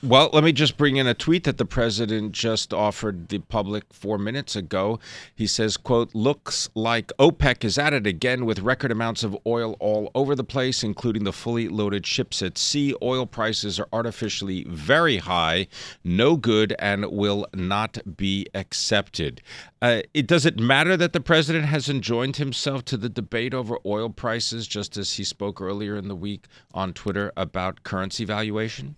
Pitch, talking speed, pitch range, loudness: 110 Hz, 180 wpm, 100-125 Hz, -23 LUFS